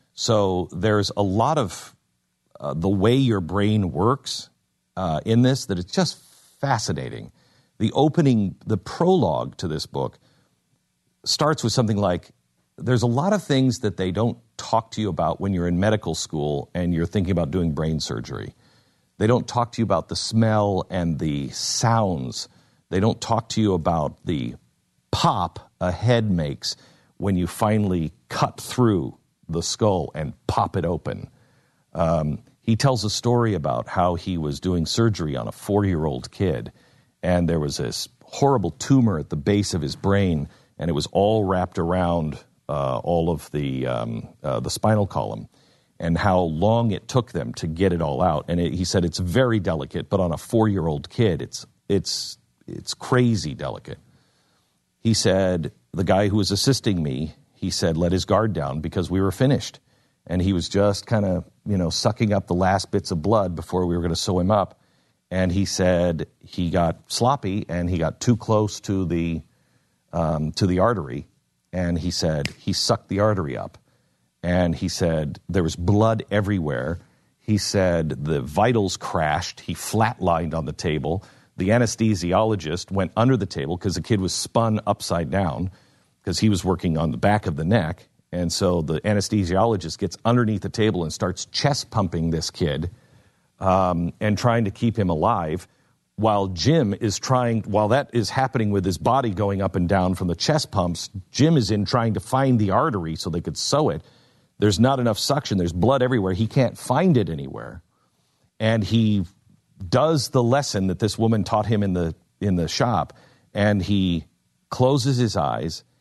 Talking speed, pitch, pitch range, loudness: 180 wpm, 95 Hz, 85-110 Hz, -23 LUFS